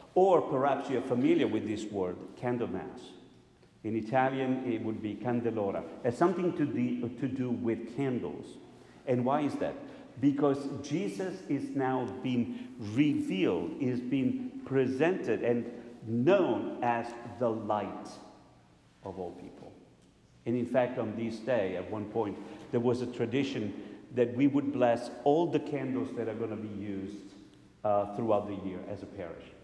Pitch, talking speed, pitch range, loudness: 120 Hz, 155 wpm, 110-135 Hz, -32 LUFS